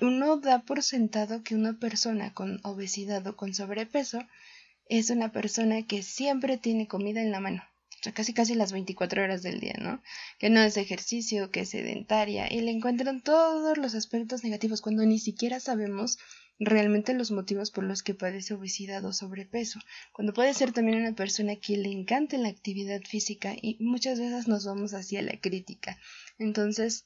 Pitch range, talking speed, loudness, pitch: 200-235 Hz, 180 wpm, -29 LUFS, 215 Hz